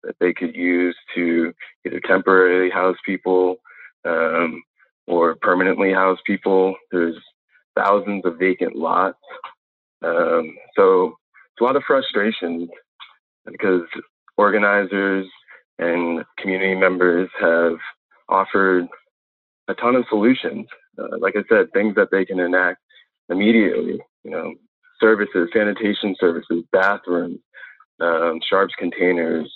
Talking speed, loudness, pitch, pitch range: 115 wpm, -19 LUFS, 95 Hz, 85-100 Hz